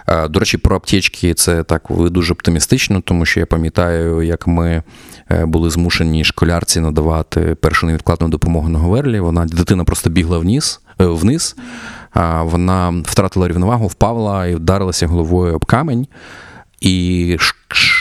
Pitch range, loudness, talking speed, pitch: 85-95 Hz, -15 LUFS, 130 wpm, 85 Hz